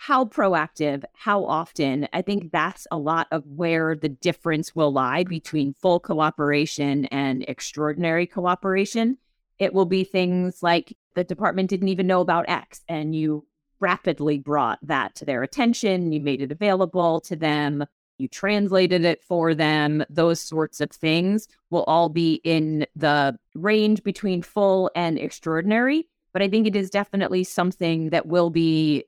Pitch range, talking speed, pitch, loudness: 155-190 Hz, 155 wpm, 170 Hz, -23 LUFS